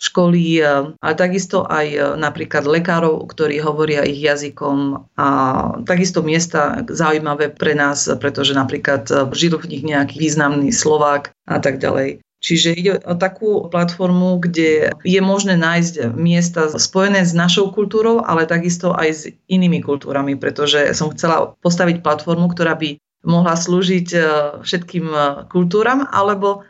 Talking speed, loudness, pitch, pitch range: 135 wpm, -16 LUFS, 165 Hz, 145-180 Hz